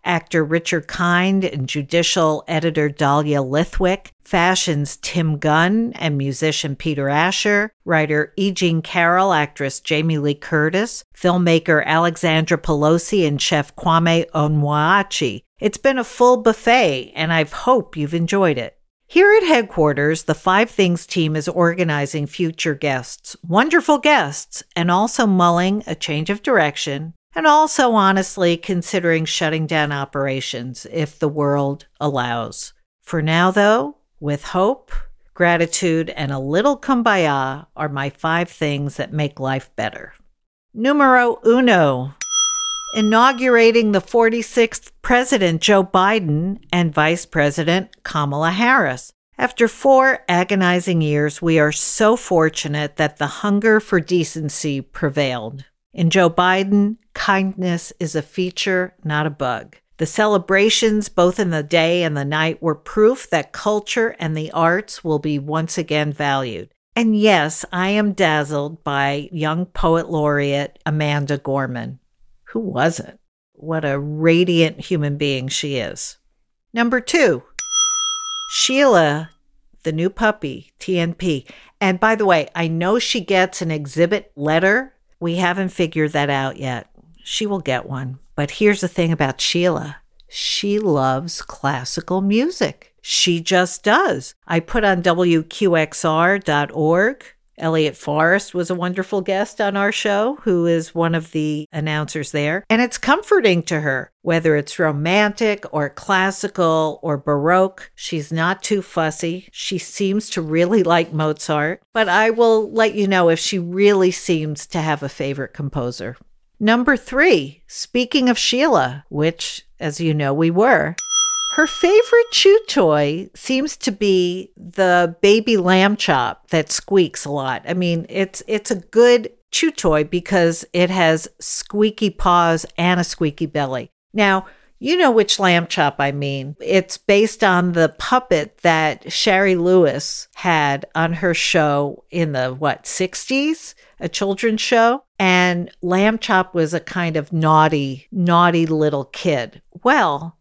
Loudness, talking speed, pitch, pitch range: -18 LUFS, 140 wpm, 175 Hz, 155-205 Hz